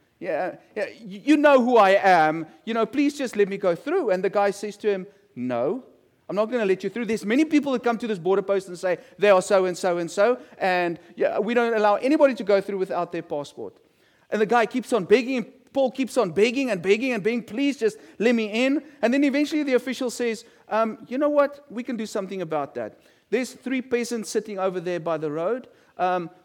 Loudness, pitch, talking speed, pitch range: -23 LUFS, 220 Hz, 235 wpm, 190-250 Hz